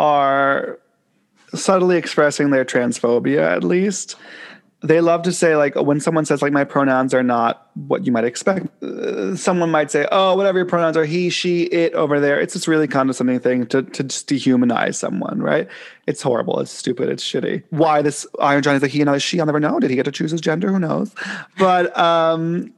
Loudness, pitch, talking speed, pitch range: -18 LUFS, 160 Hz, 210 wpm, 145-180 Hz